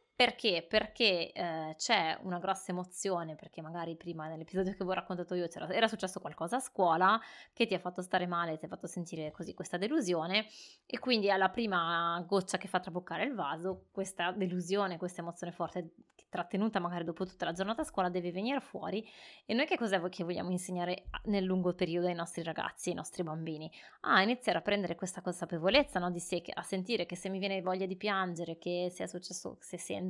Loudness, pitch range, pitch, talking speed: -34 LUFS, 175-195 Hz, 180 Hz, 205 wpm